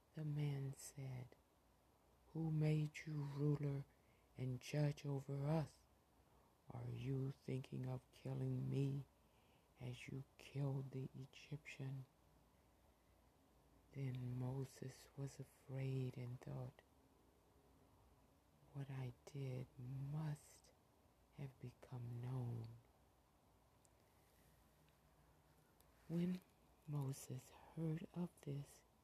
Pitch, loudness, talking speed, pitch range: 135 Hz, -48 LUFS, 85 wpm, 125-145 Hz